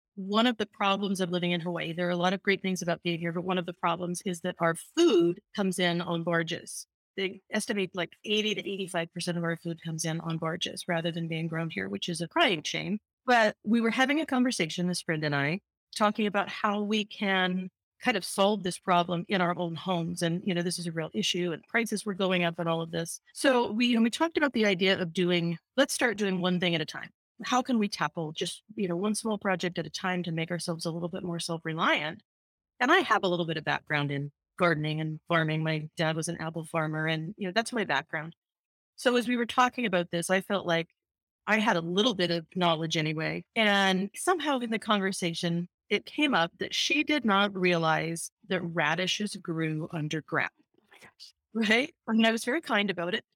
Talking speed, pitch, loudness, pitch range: 230 wpm, 180 Hz, -29 LUFS, 165-210 Hz